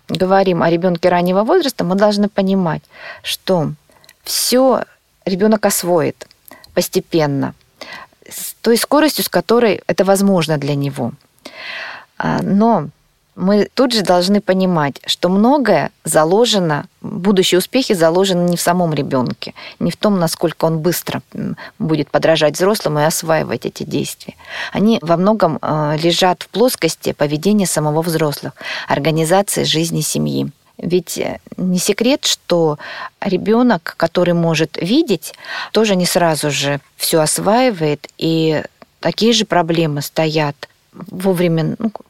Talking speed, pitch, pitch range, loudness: 120 wpm, 180 Hz, 160-205 Hz, -16 LUFS